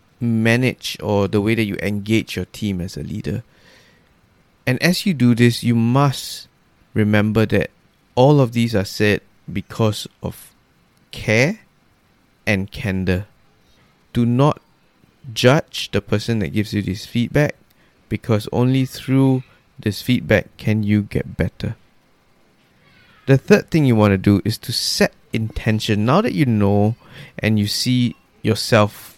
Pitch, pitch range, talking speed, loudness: 110 Hz, 105-125 Hz, 140 wpm, -19 LUFS